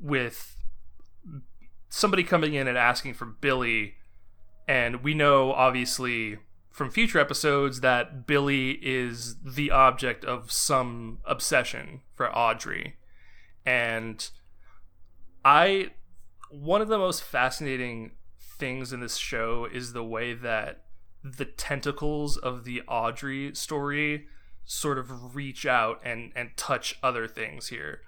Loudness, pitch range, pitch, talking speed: -27 LUFS, 105-140 Hz, 125 Hz, 120 wpm